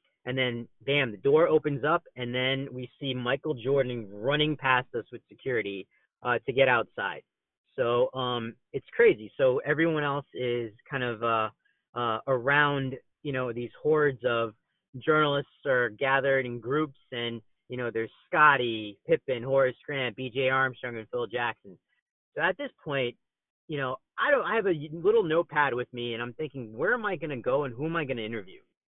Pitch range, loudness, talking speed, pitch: 120-150 Hz, -28 LUFS, 185 wpm, 130 Hz